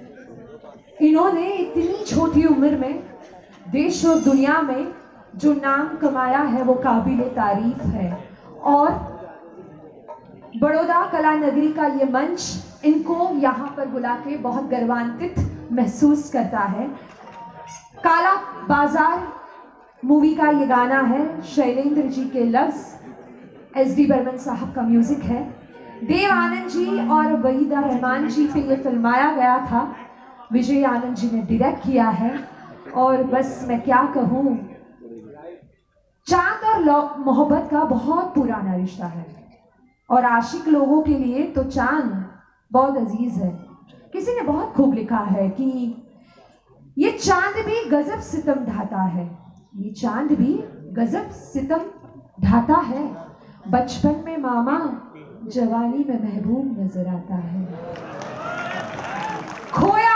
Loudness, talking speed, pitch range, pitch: -20 LUFS, 125 wpm, 235-295 Hz, 260 Hz